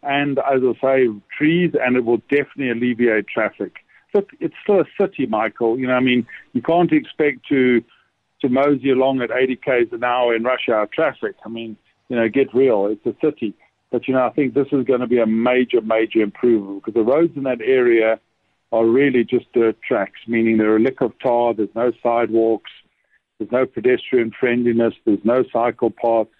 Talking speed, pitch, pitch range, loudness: 200 wpm, 125 Hz, 115-135 Hz, -18 LUFS